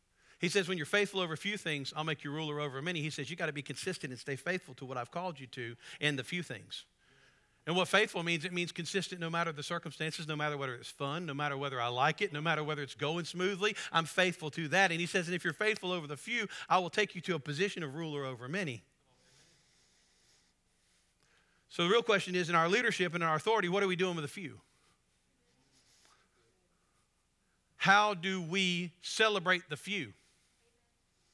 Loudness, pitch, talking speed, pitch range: -33 LUFS, 165 Hz, 215 wpm, 145-185 Hz